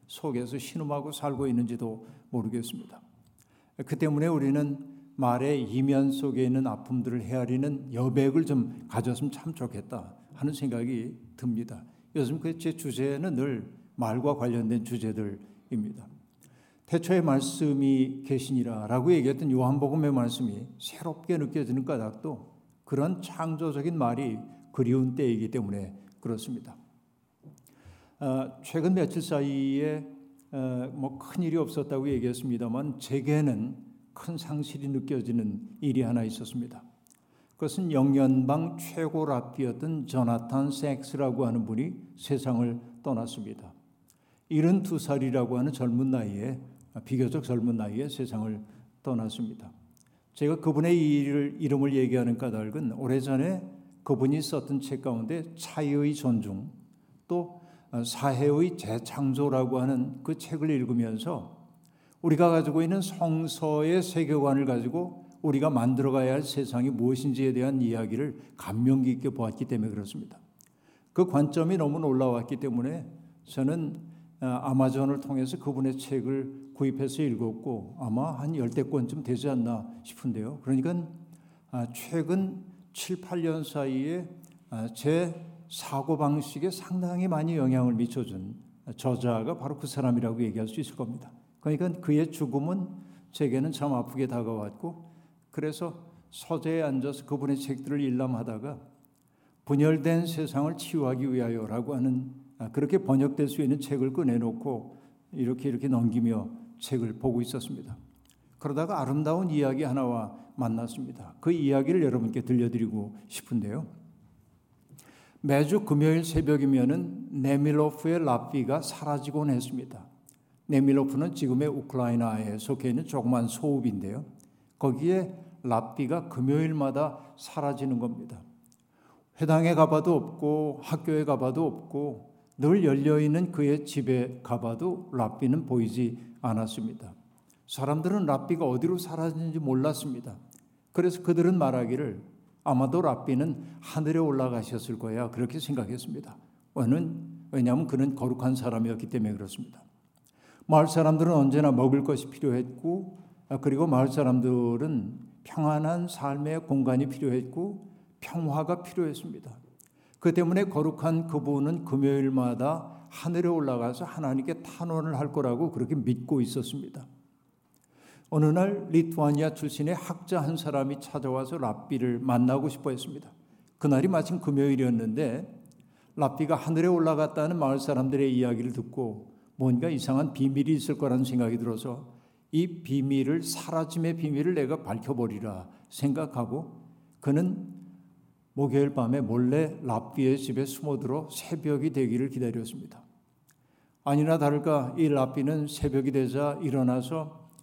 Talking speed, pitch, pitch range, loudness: 305 characters per minute, 140 Hz, 125-155 Hz, -29 LUFS